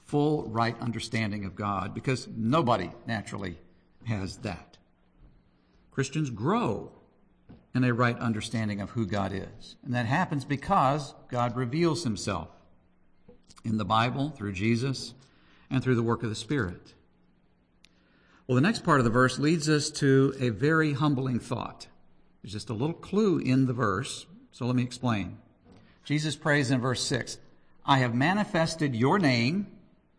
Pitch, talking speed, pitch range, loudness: 120 Hz, 150 wpm, 100-140 Hz, -28 LUFS